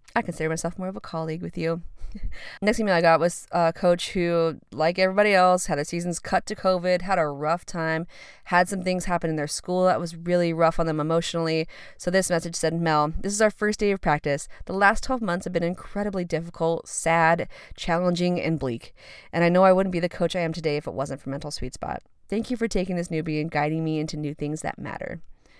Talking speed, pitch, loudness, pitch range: 235 wpm, 170 Hz, -25 LUFS, 160-185 Hz